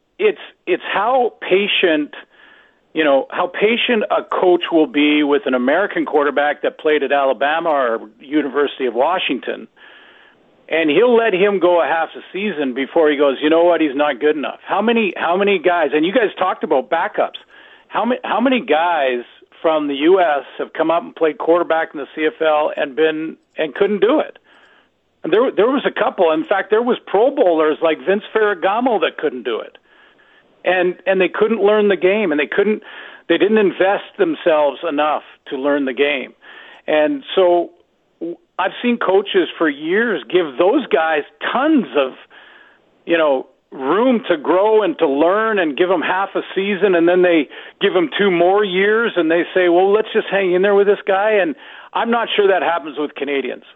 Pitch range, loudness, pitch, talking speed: 155-215 Hz, -16 LUFS, 180 Hz, 190 wpm